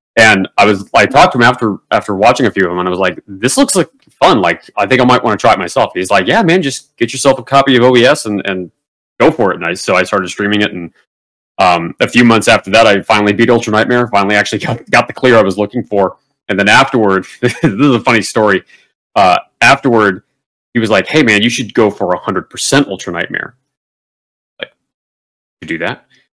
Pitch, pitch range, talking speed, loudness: 110 Hz, 100-125 Hz, 240 wpm, -11 LUFS